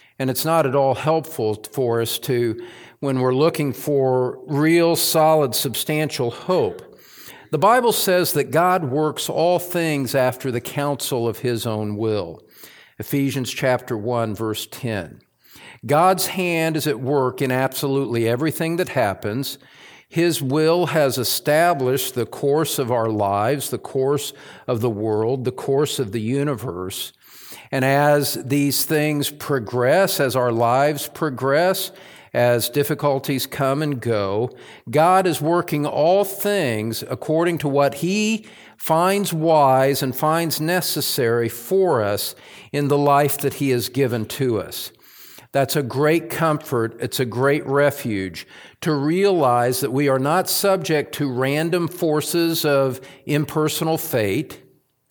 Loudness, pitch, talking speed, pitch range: -20 LUFS, 140 Hz, 135 wpm, 125-160 Hz